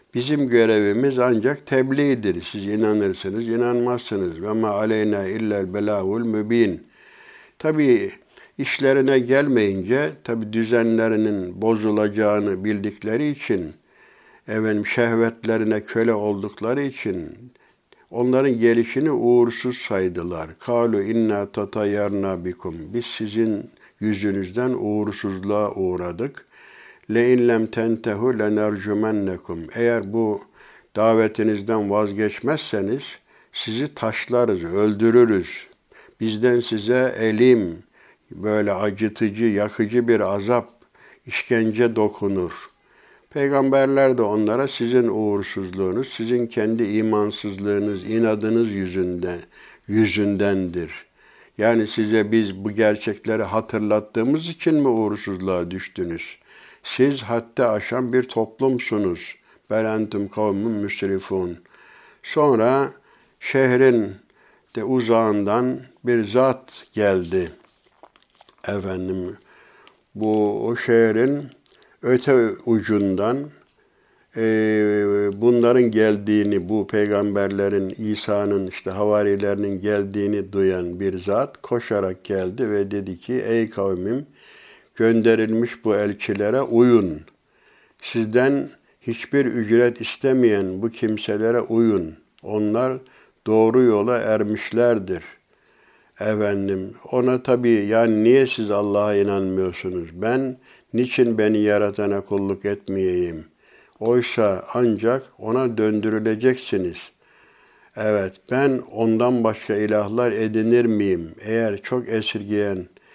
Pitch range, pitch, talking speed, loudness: 100-120 Hz, 110 Hz, 85 wpm, -21 LUFS